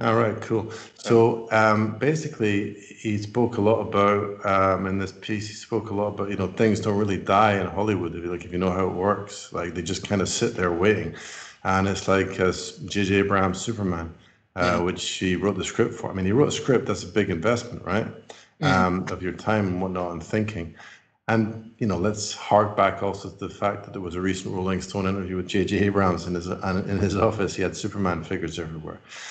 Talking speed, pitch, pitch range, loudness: 220 wpm, 100 Hz, 95-105 Hz, -24 LUFS